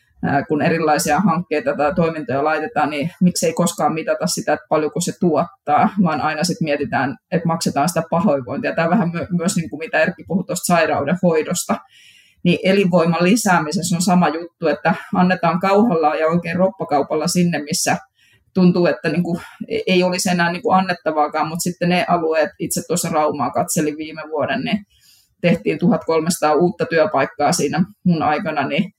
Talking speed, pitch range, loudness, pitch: 160 wpm, 155-180 Hz, -18 LUFS, 170 Hz